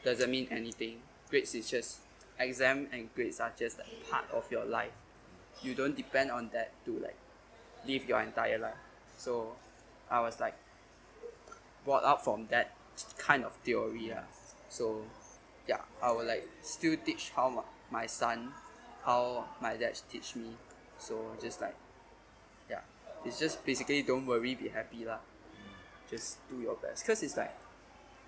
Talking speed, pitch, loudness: 155 wpm, 130 Hz, -36 LUFS